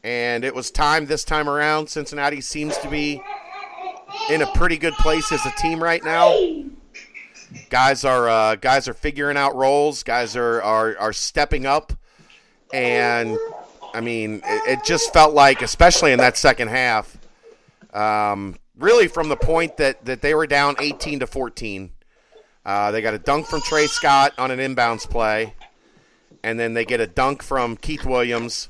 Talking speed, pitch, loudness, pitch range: 170 wpm, 140 Hz, -19 LUFS, 115-155 Hz